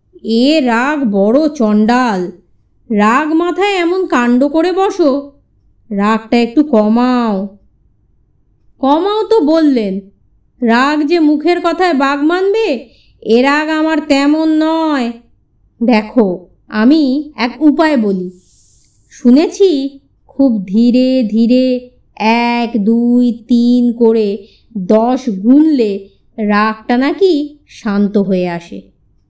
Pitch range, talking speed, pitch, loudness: 220-300 Hz, 95 wpm, 245 Hz, -12 LUFS